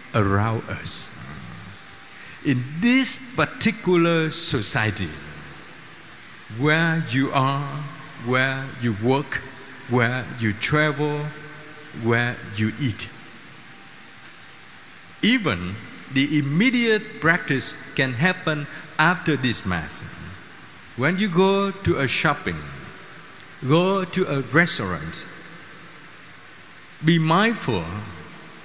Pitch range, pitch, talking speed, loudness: 120-165 Hz, 145 Hz, 80 wpm, -21 LUFS